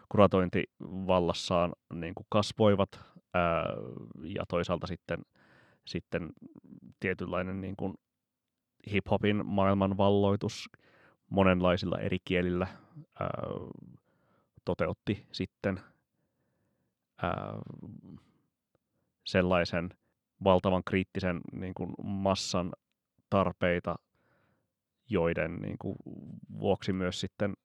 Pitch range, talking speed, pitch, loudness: 90-100 Hz, 75 wpm, 95 Hz, -32 LUFS